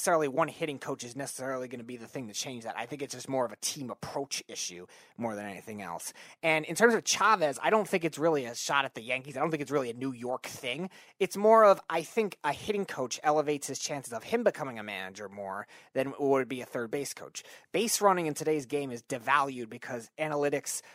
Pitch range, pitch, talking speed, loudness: 125-160 Hz, 140 Hz, 245 wpm, -30 LUFS